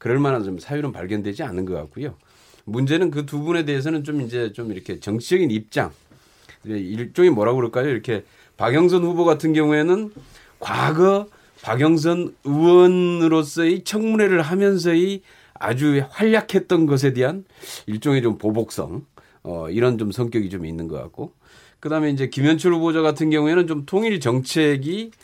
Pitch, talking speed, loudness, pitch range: 150 Hz, 330 characters per minute, -20 LUFS, 120-175 Hz